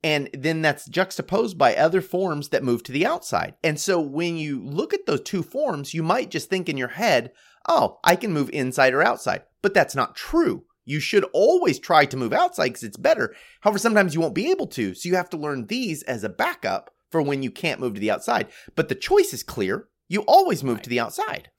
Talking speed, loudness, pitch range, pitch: 235 wpm, -23 LUFS, 140-210 Hz, 165 Hz